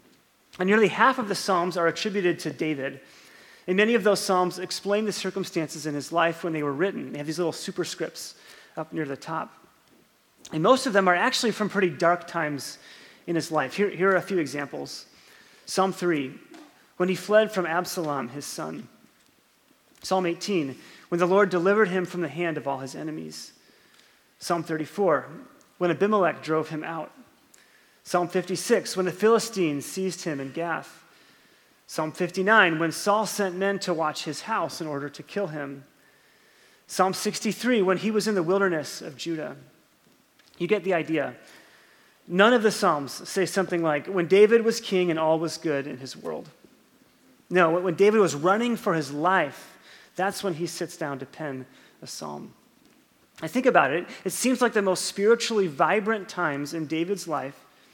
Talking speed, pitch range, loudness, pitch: 175 wpm, 160-200 Hz, -25 LUFS, 180 Hz